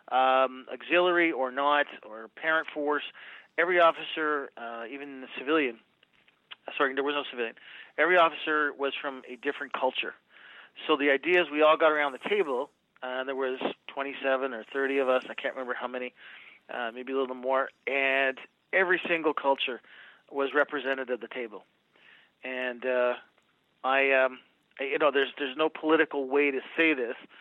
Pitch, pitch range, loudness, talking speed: 140 Hz, 130-150 Hz, -28 LUFS, 175 wpm